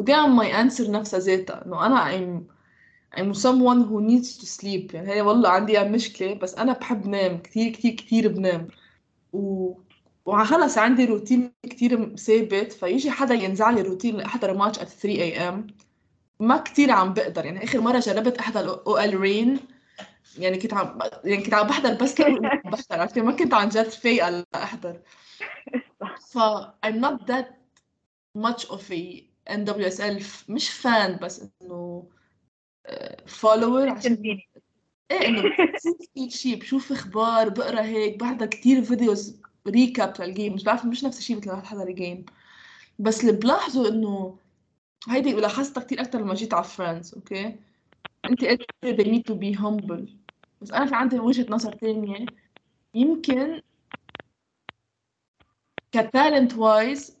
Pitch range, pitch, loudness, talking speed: 200-250 Hz, 220 Hz, -23 LUFS, 150 wpm